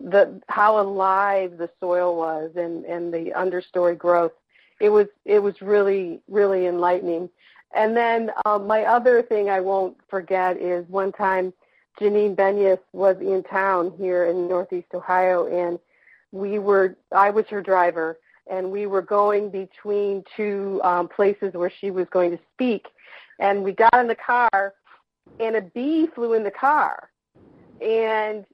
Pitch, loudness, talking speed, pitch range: 195 Hz, -22 LUFS, 155 wpm, 180-210 Hz